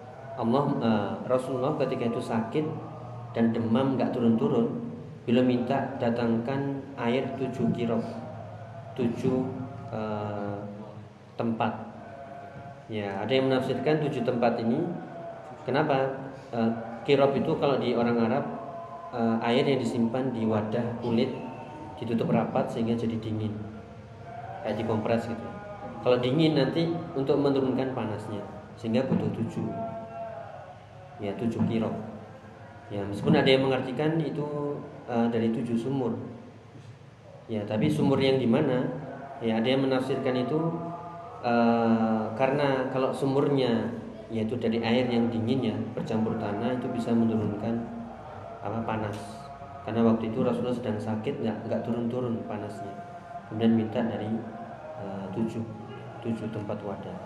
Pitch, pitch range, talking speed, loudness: 120 Hz, 115-135 Hz, 125 wpm, -28 LUFS